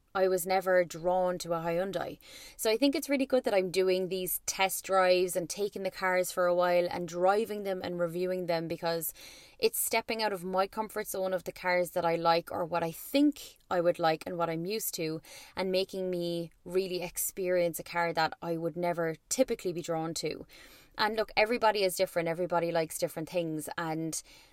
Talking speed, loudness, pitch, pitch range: 205 wpm, -31 LUFS, 180 Hz, 170-190 Hz